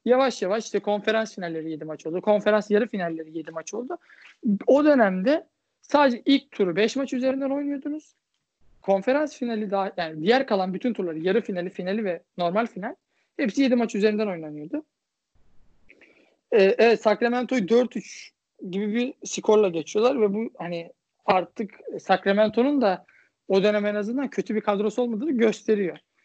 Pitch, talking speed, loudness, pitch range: 215 Hz, 150 wpm, -24 LUFS, 190-250 Hz